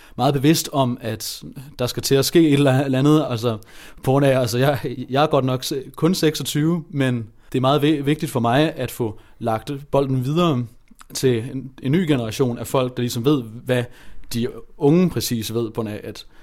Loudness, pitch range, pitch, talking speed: -20 LUFS, 120-145 Hz, 130 Hz, 200 wpm